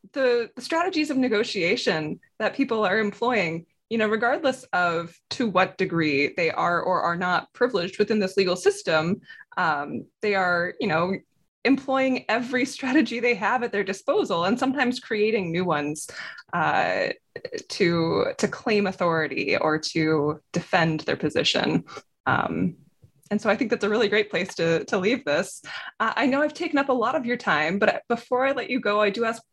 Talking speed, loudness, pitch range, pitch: 180 wpm, -24 LUFS, 175-255 Hz, 215 Hz